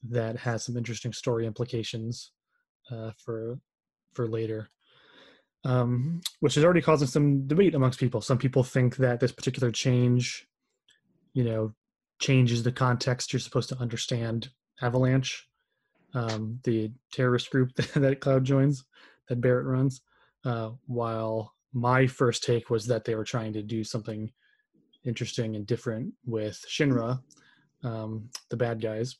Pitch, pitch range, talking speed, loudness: 125 Hz, 115-135 Hz, 140 wpm, -28 LUFS